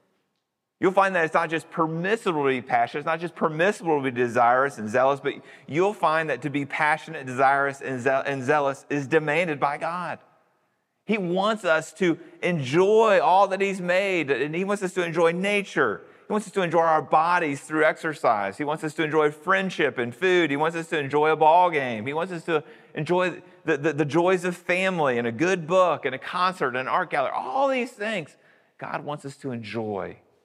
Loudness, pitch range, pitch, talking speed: -24 LUFS, 145-185 Hz, 160 Hz, 205 wpm